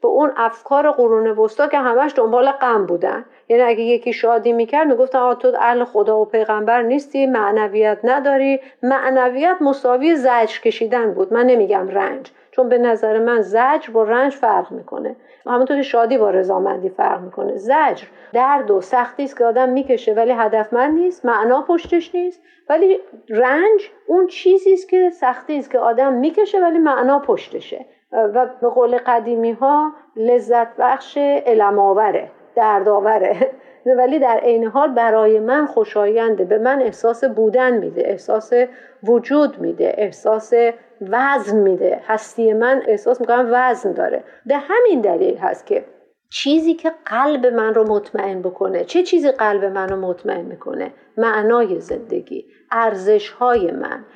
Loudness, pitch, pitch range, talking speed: -16 LUFS, 245 Hz, 225-285 Hz, 150 wpm